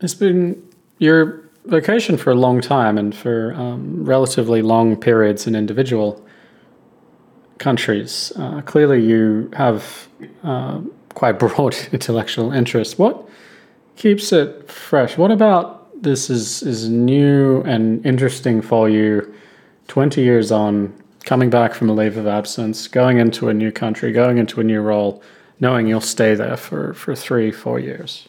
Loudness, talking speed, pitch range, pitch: -17 LUFS, 145 wpm, 110-135 Hz, 115 Hz